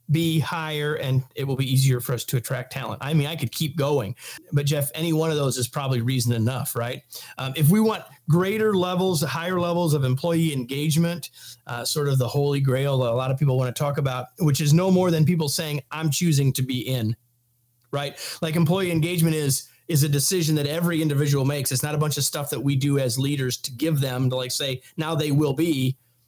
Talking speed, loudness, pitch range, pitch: 230 wpm, -23 LUFS, 130-160 Hz, 145 Hz